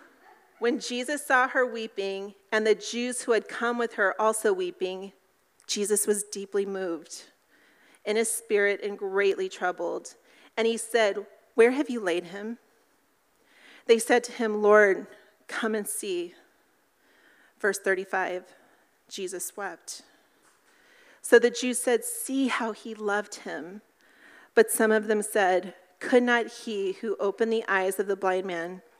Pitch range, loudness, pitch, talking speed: 195-240 Hz, -26 LUFS, 220 Hz, 145 wpm